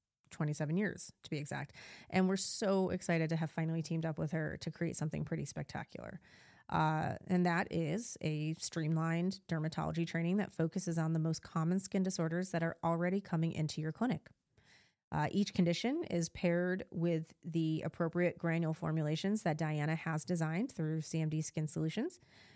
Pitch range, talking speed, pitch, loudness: 160-180 Hz, 165 wpm, 165 Hz, -36 LUFS